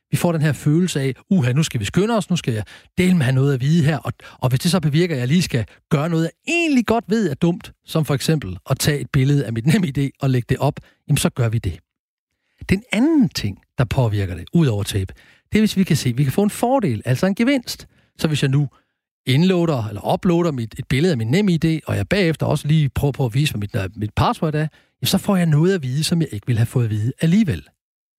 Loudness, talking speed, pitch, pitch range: -19 LUFS, 270 wpm, 150 Hz, 125-175 Hz